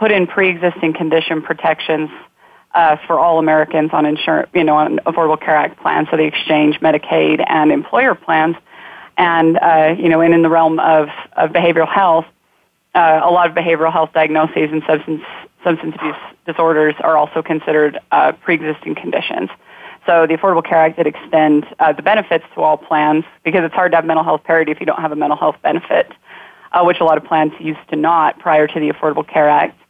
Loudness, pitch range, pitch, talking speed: -14 LUFS, 155-165 Hz, 160 Hz, 200 wpm